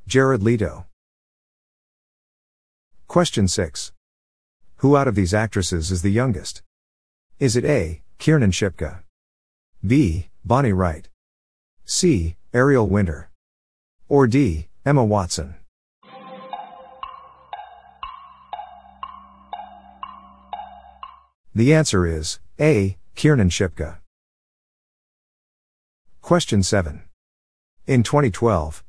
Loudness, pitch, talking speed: -20 LUFS, 100 Hz, 75 wpm